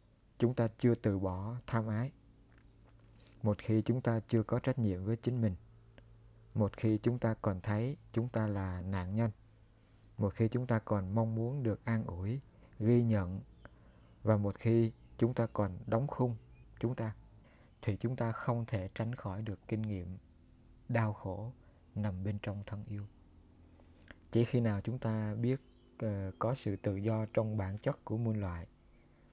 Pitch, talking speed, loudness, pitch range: 110 Hz, 175 wpm, -36 LUFS, 100-115 Hz